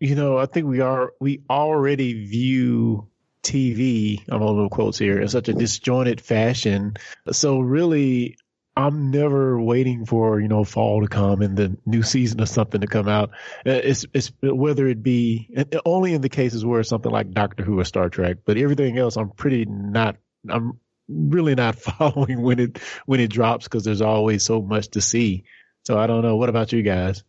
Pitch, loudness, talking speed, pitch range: 115 Hz, -21 LUFS, 195 wpm, 105-130 Hz